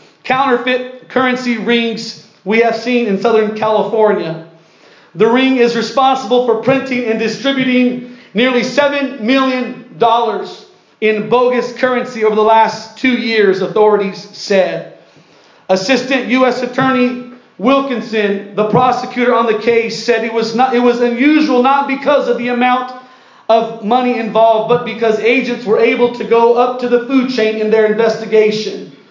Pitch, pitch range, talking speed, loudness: 240 Hz, 220-250 Hz, 145 wpm, -13 LUFS